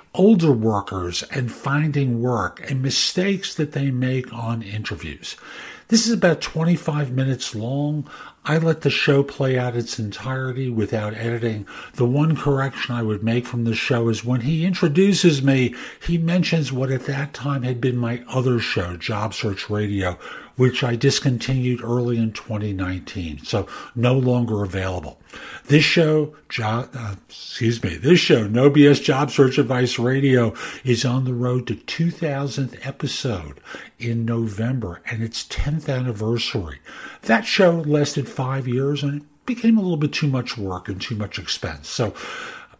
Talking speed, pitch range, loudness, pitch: 155 wpm, 115-145 Hz, -21 LUFS, 125 Hz